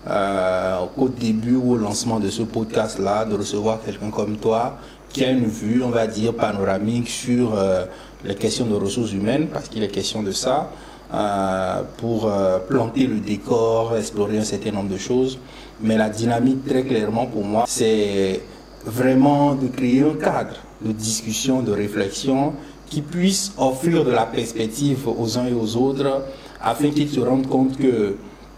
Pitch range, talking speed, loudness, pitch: 105-130 Hz, 170 wpm, -21 LUFS, 115 Hz